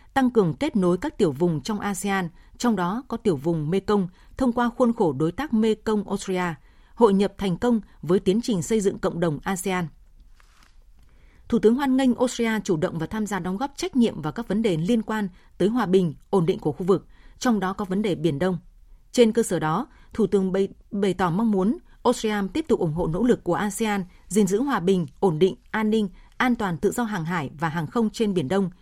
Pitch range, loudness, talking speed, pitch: 180-225 Hz, -24 LUFS, 225 wpm, 200 Hz